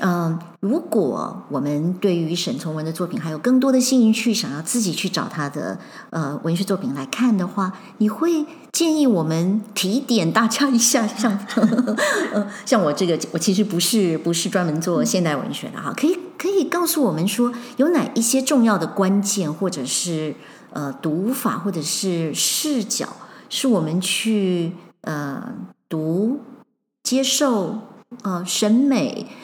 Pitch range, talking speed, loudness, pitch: 175-250 Hz, 230 characters per minute, -20 LUFS, 210 Hz